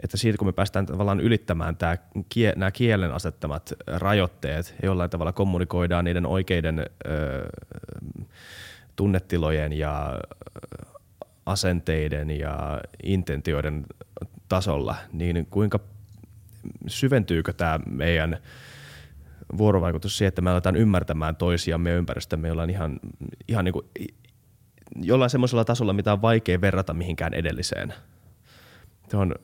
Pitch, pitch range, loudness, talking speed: 90 Hz, 80-105 Hz, -25 LUFS, 110 wpm